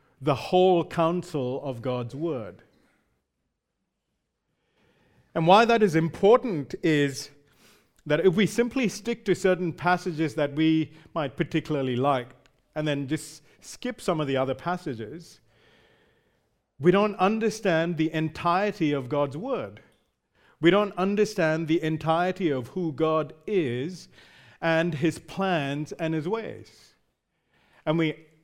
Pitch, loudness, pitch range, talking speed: 160 Hz, -26 LUFS, 145-180 Hz, 125 wpm